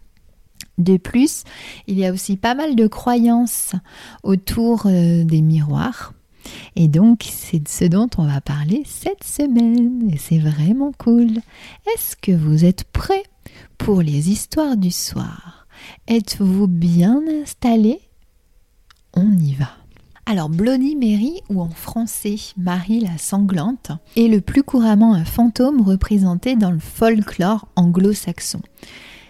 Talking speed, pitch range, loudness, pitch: 130 wpm, 175-235 Hz, -17 LUFS, 205 Hz